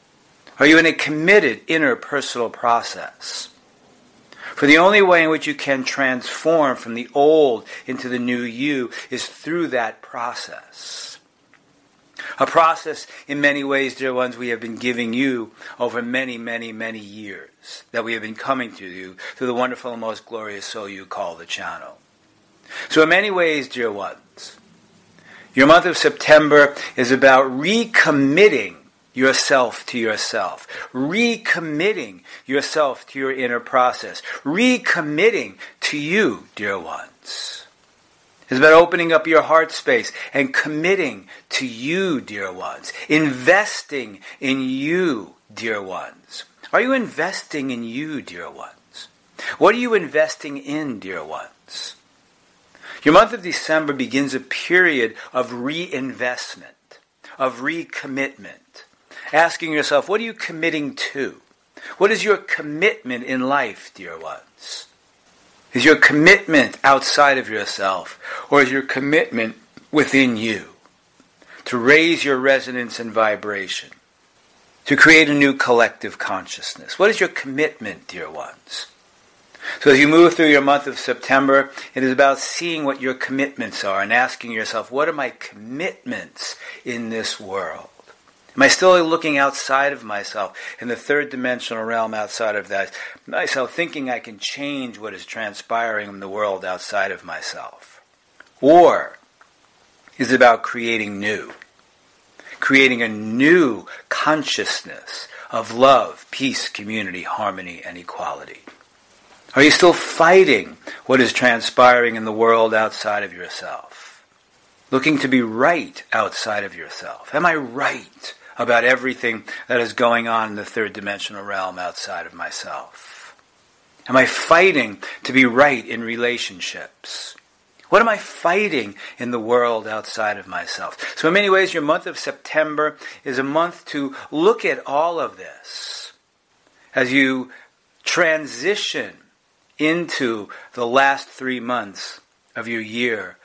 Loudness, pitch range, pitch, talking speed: -18 LUFS, 120-155 Hz, 135 Hz, 140 wpm